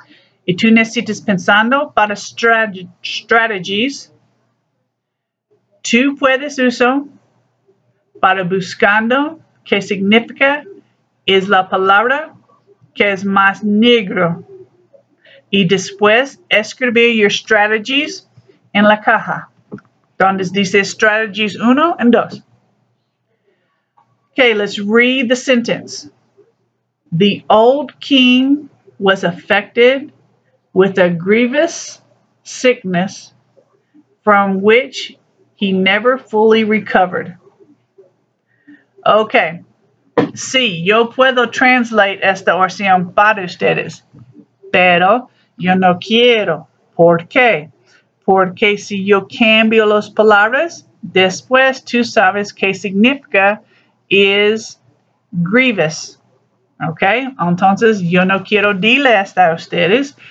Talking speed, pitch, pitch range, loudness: 95 wpm, 215 Hz, 195-250 Hz, -13 LUFS